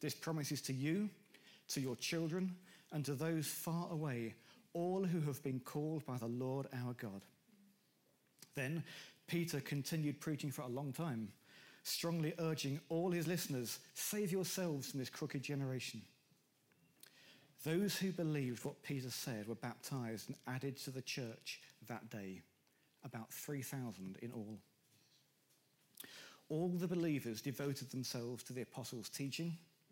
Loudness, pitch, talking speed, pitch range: -43 LUFS, 140 Hz, 140 wpm, 125-165 Hz